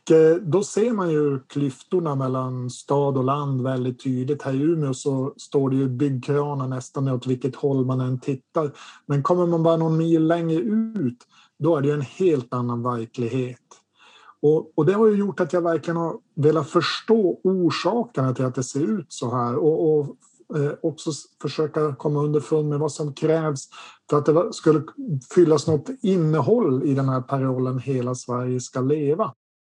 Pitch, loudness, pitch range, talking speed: 145 Hz, -23 LUFS, 130-165 Hz, 180 wpm